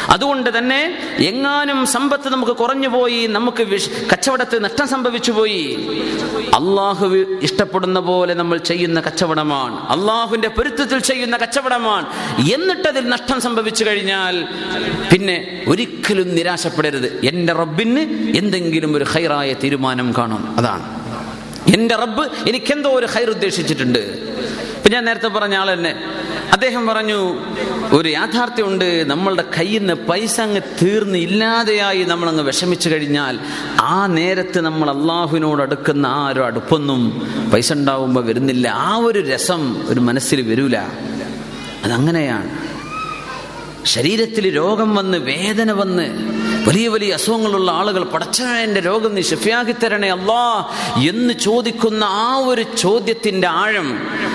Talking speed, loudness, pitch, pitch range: 110 wpm, -17 LUFS, 200 Hz, 170-230 Hz